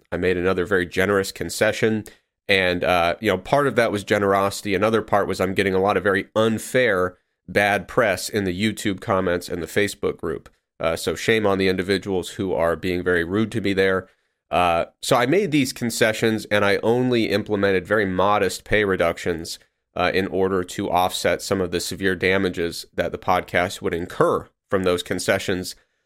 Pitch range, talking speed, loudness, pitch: 90-105 Hz, 185 wpm, -21 LUFS, 95 Hz